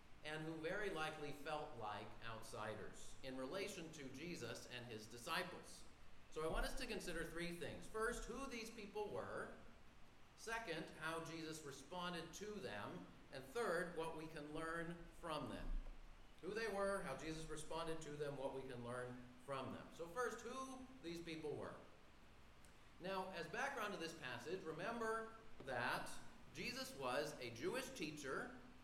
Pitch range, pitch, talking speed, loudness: 150-200 Hz, 165 Hz, 155 wpm, -49 LUFS